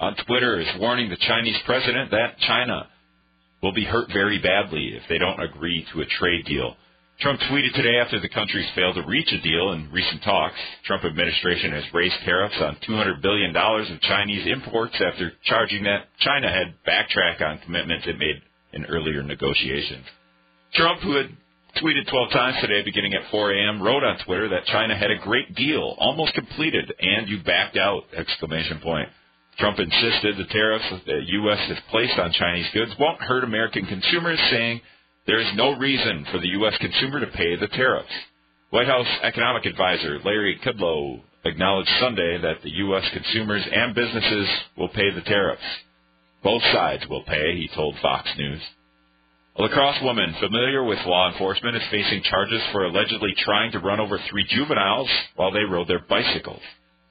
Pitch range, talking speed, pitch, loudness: 75-110 Hz, 175 wpm, 95 Hz, -22 LUFS